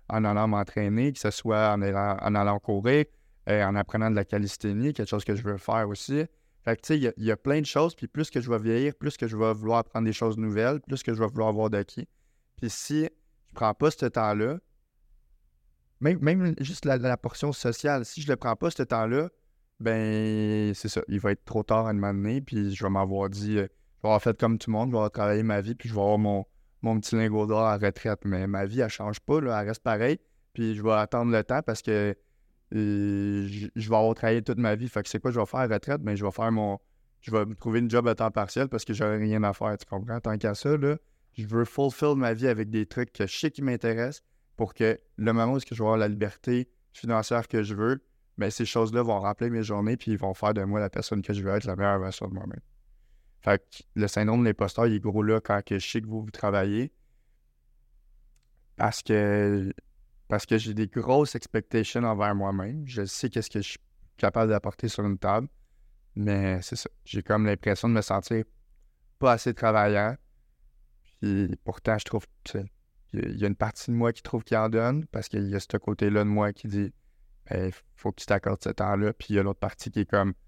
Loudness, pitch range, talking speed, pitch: -28 LUFS, 100-120 Hz, 245 wpm, 110 Hz